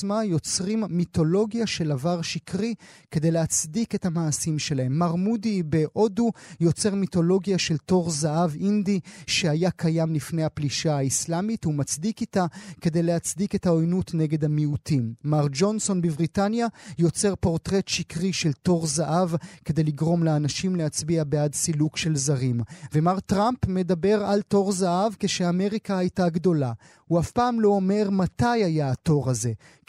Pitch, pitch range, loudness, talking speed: 175 Hz, 155-195 Hz, -24 LUFS, 135 wpm